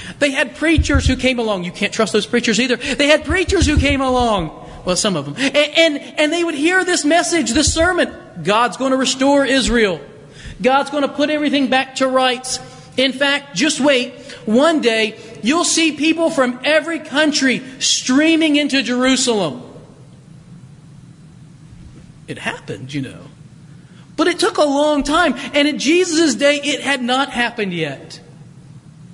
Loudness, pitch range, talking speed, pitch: -16 LUFS, 185-295 Hz, 165 wpm, 260 Hz